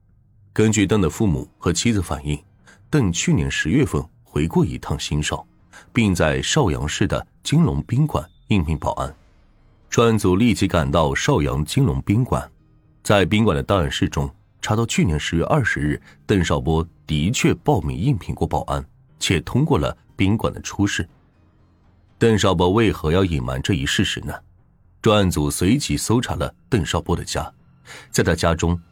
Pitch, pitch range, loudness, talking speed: 90 Hz, 75-105 Hz, -20 LUFS, 245 characters per minute